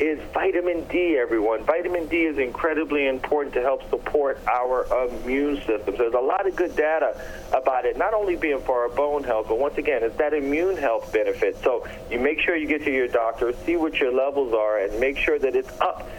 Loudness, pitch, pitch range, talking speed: -23 LUFS, 150 Hz, 130-180 Hz, 220 wpm